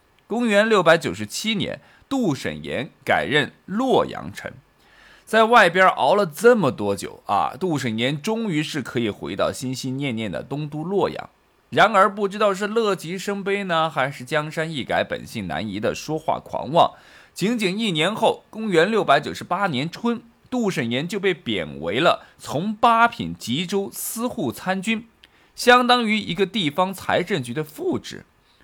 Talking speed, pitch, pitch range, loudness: 240 characters per minute, 190 Hz, 150-220 Hz, -21 LUFS